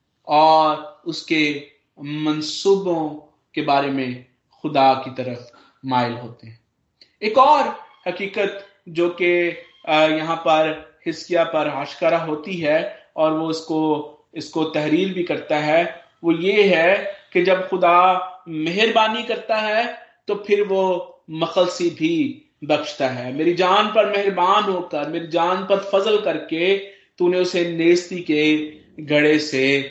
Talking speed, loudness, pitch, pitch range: 125 wpm, -20 LUFS, 170 Hz, 150-195 Hz